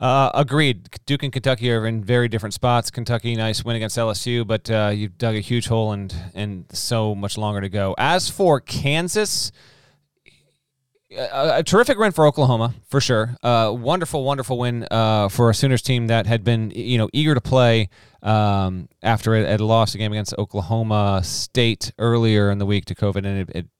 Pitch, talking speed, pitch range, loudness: 115 Hz, 190 wpm, 105-125 Hz, -20 LUFS